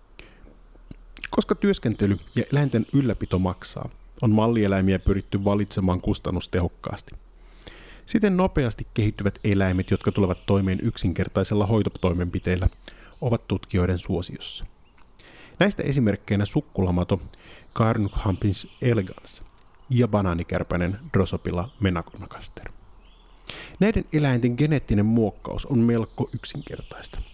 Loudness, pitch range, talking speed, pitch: -24 LUFS, 95-115 Hz, 85 wpm, 100 Hz